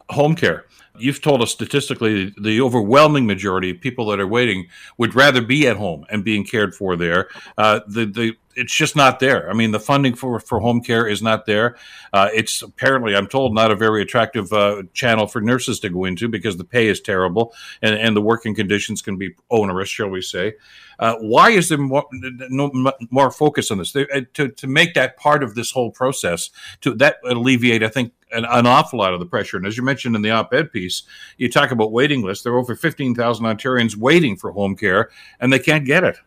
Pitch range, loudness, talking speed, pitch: 105-130 Hz, -18 LUFS, 220 wpm, 115 Hz